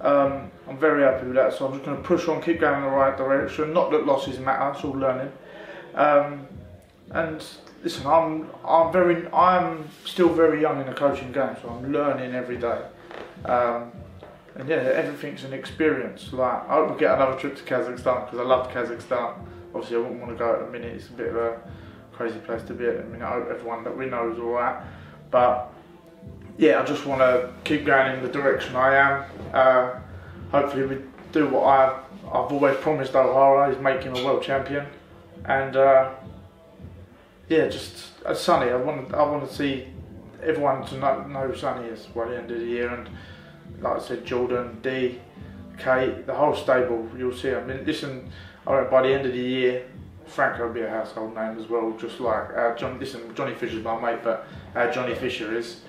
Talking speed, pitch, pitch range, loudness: 200 wpm, 130 Hz, 120-140 Hz, -24 LUFS